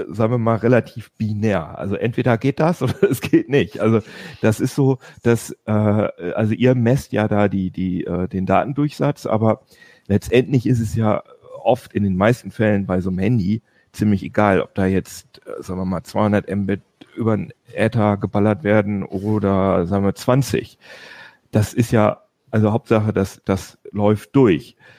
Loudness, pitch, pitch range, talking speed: -19 LUFS, 105 Hz, 100-120 Hz, 175 wpm